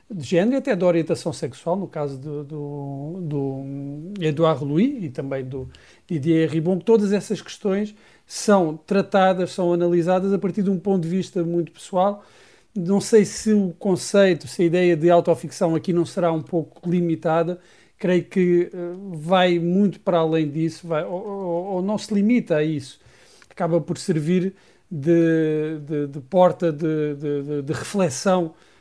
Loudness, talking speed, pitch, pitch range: -22 LUFS, 165 wpm, 175 Hz, 155-190 Hz